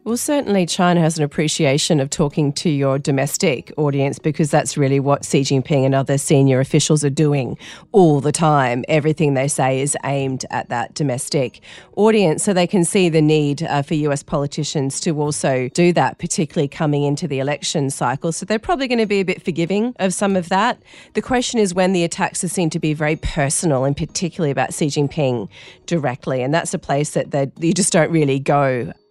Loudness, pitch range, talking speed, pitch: -18 LUFS, 140-180 Hz, 200 wpm, 155 Hz